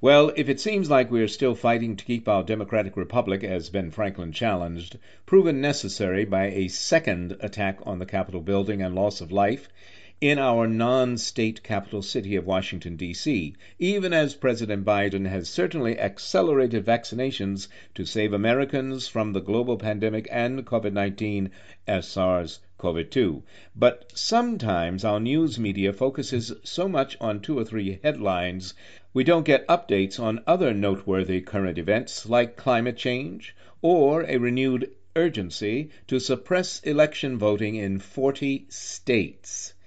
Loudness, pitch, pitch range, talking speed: -25 LUFS, 105 Hz, 95-130 Hz, 145 wpm